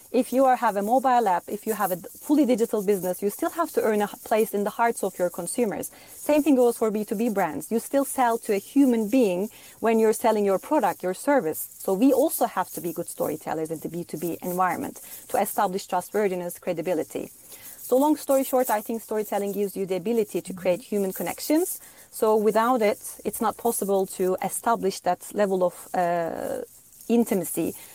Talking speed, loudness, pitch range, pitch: 195 wpm, -25 LUFS, 185-245 Hz, 215 Hz